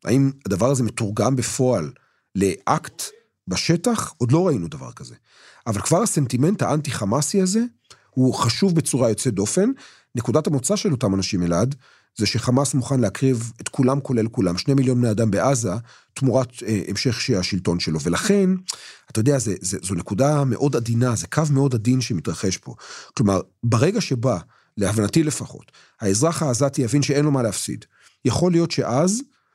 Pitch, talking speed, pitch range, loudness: 130 Hz, 155 wpm, 110-145 Hz, -21 LUFS